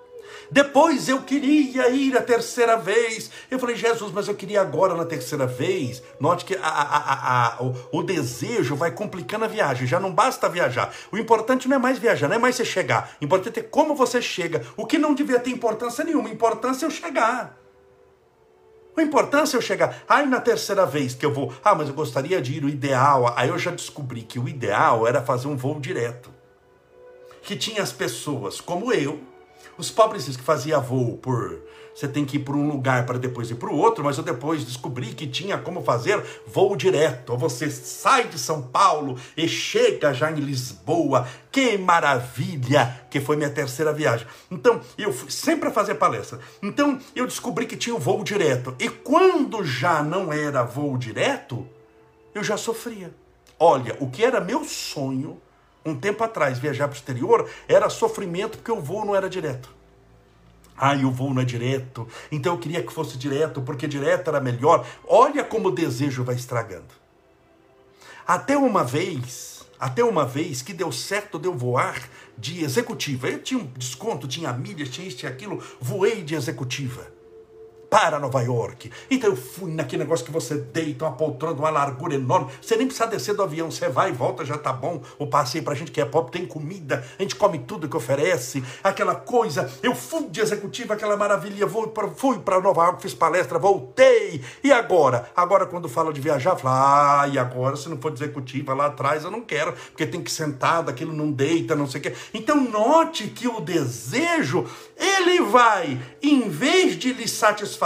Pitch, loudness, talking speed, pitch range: 165 Hz, -23 LUFS, 195 wpm, 140-225 Hz